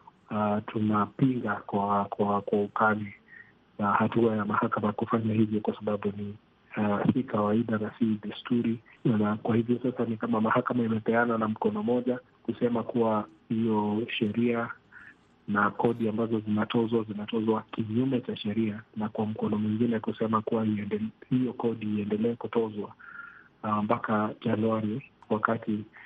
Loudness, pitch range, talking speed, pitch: -29 LUFS, 105-115 Hz, 135 wpm, 110 Hz